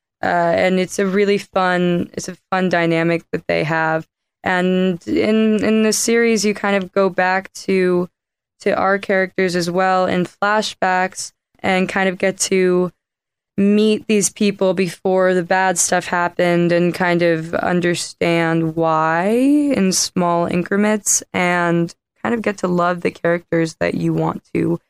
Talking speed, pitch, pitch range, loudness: 155 wpm, 185 Hz, 175-195 Hz, -17 LUFS